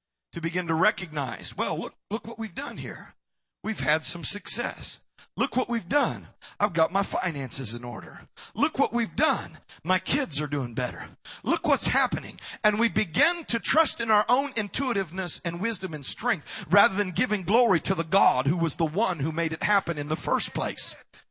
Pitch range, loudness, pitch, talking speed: 160-230 Hz, -27 LUFS, 195 Hz, 195 wpm